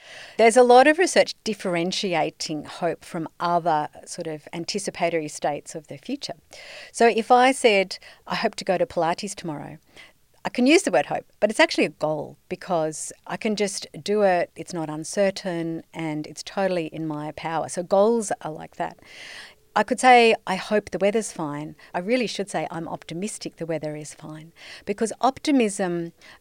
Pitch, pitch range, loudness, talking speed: 180 Hz, 160-215 Hz, -23 LUFS, 175 wpm